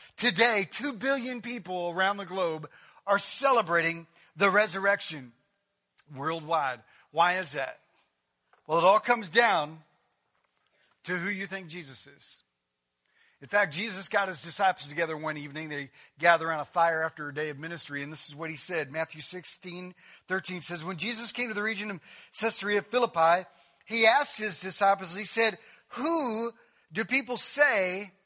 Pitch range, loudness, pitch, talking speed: 160-215 Hz, -28 LUFS, 185 Hz, 155 wpm